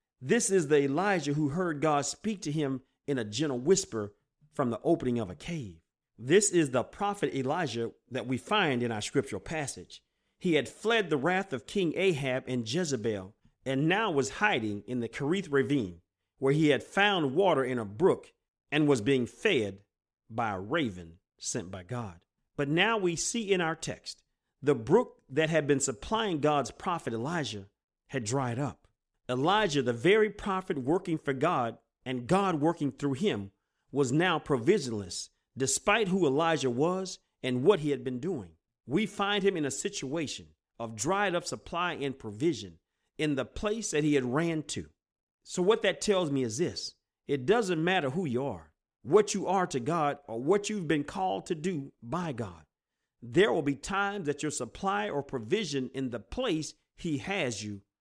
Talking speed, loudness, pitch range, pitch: 180 wpm, -30 LUFS, 120-175 Hz, 145 Hz